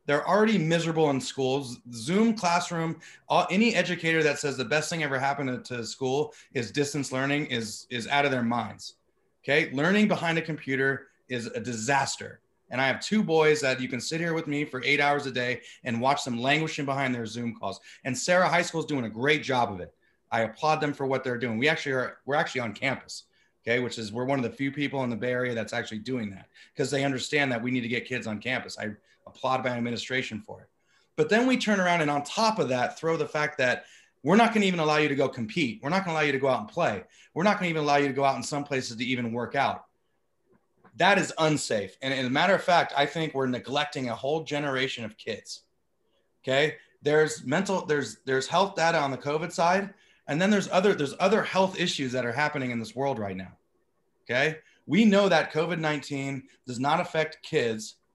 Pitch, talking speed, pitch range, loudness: 140 Hz, 230 wpm, 125-160 Hz, -27 LUFS